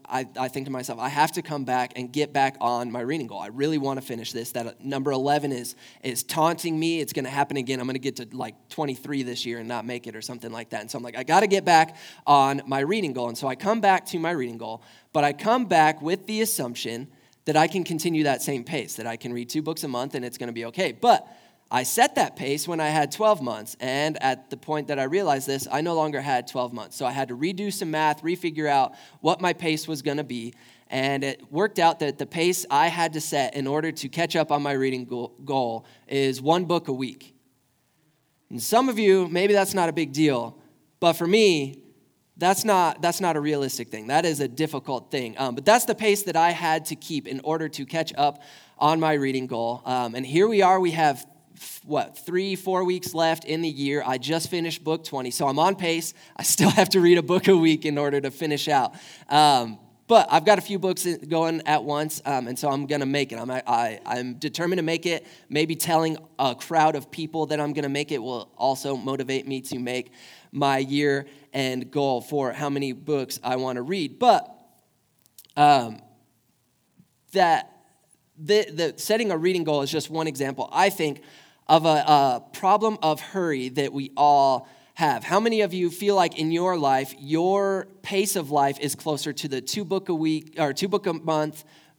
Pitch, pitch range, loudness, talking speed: 150 Hz, 135-165 Hz, -24 LUFS, 235 wpm